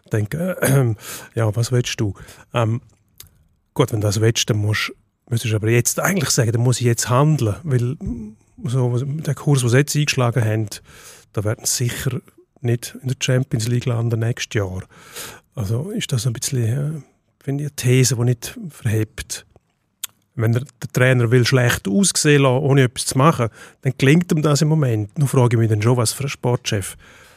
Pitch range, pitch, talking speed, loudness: 115-140 Hz, 125 Hz, 185 wpm, -19 LUFS